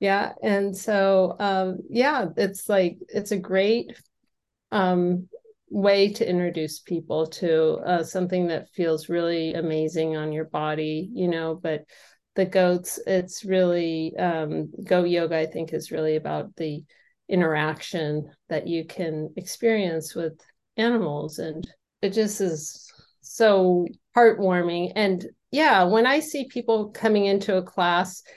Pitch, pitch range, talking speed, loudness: 180 Hz, 160-200 Hz, 135 wpm, -24 LUFS